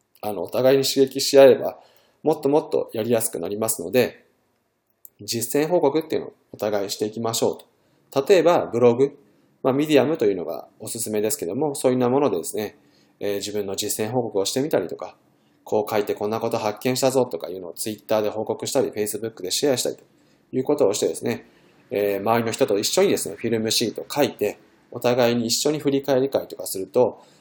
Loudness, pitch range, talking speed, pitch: -22 LUFS, 105-135 Hz, 460 characters per minute, 115 Hz